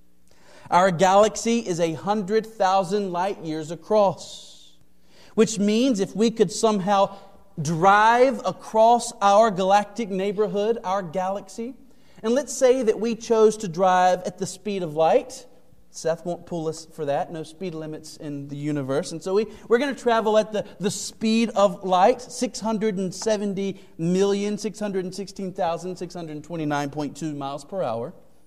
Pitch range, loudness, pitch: 170-220 Hz, -23 LUFS, 195 Hz